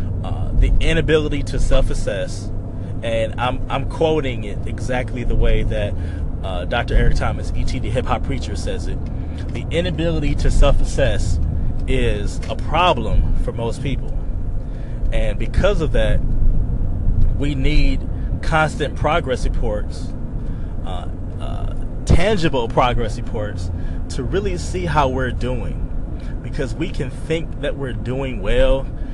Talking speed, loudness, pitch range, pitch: 125 wpm, -22 LUFS, 90-120 Hz, 105 Hz